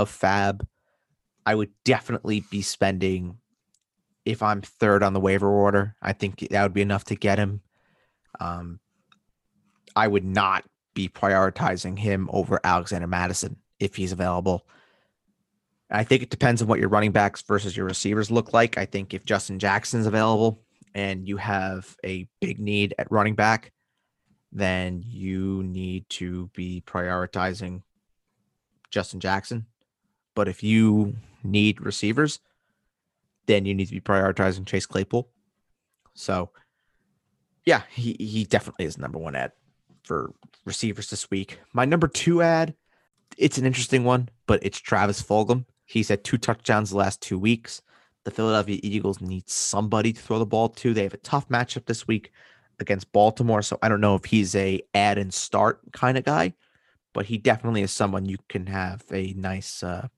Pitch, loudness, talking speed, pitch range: 100 Hz, -24 LUFS, 160 wpm, 95-110 Hz